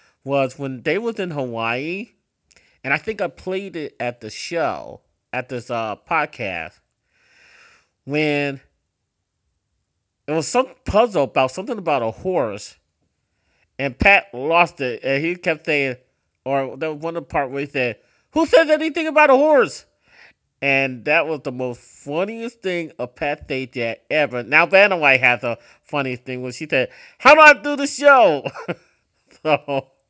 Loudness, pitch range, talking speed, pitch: -19 LUFS, 125-185 Hz, 165 wpm, 140 Hz